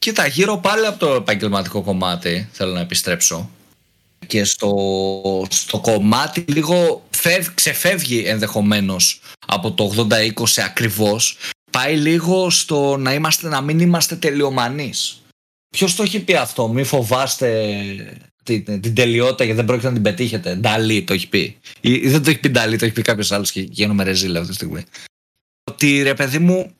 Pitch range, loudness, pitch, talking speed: 100-150 Hz, -17 LUFS, 115 Hz, 160 wpm